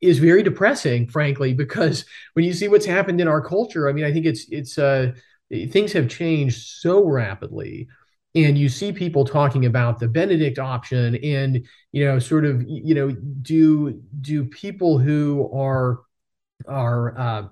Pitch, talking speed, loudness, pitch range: 145 Hz, 165 wpm, -20 LUFS, 130-160 Hz